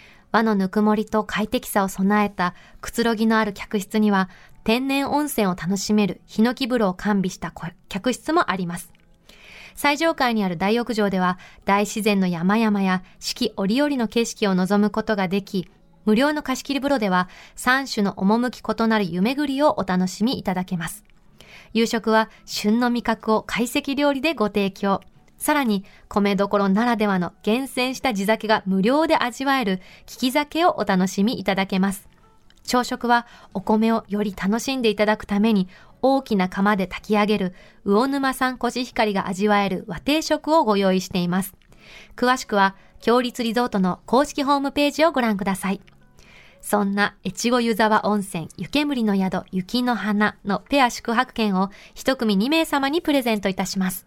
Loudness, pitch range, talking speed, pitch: -22 LUFS, 195-245 Hz, 320 characters per minute, 215 Hz